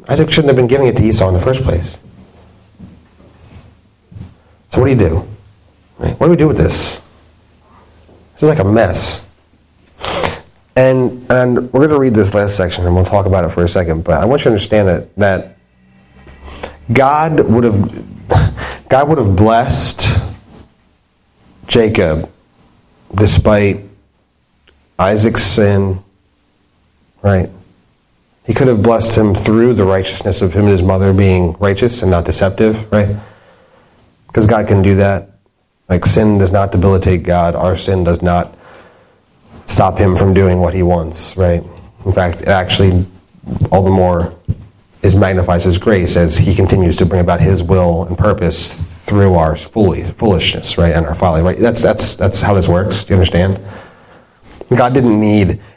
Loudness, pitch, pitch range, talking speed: -12 LUFS, 95 Hz, 90-105 Hz, 160 wpm